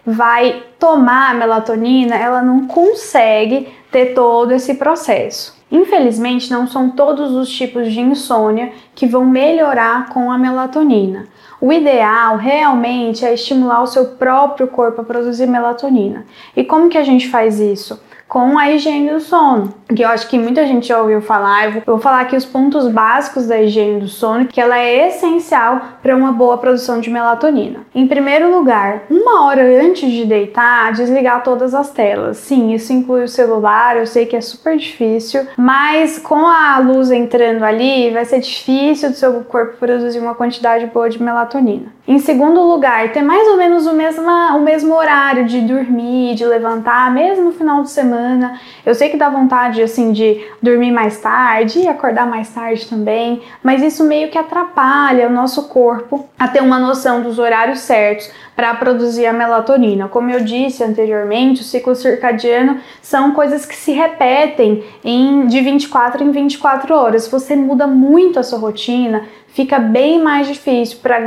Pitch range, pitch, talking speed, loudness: 235-280 Hz, 250 Hz, 175 wpm, -12 LUFS